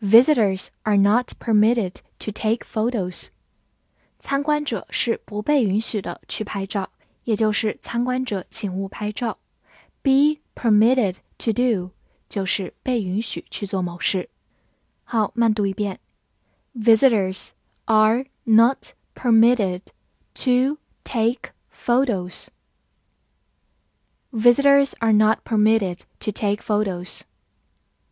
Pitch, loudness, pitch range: 215 Hz, -22 LUFS, 185-235 Hz